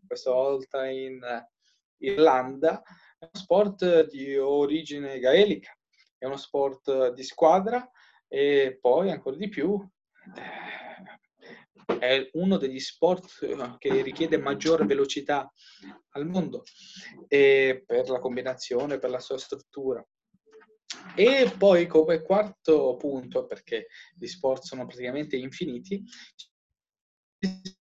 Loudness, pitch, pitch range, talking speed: -26 LUFS, 155 Hz, 135-200 Hz, 100 wpm